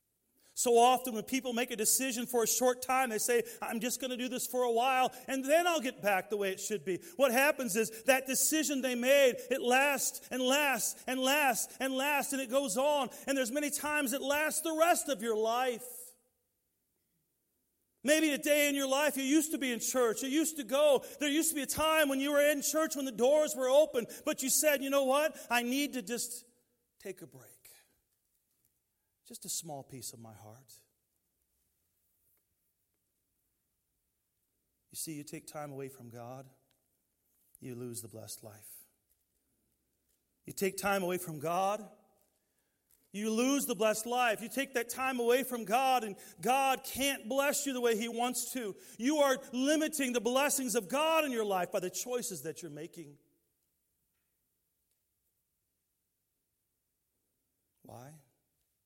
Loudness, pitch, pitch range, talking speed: -31 LUFS, 245 Hz, 170-275 Hz, 175 wpm